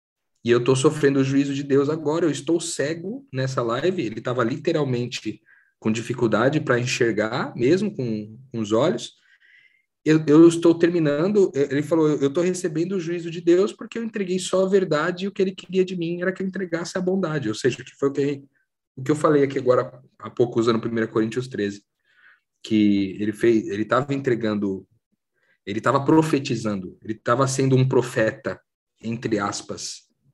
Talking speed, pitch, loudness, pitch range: 185 wpm, 140 Hz, -22 LUFS, 120-175 Hz